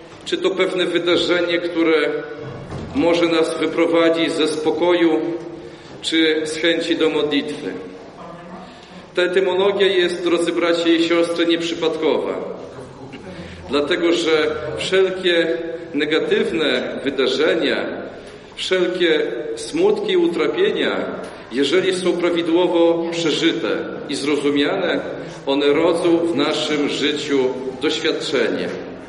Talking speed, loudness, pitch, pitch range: 90 wpm, -19 LUFS, 170 Hz, 155-175 Hz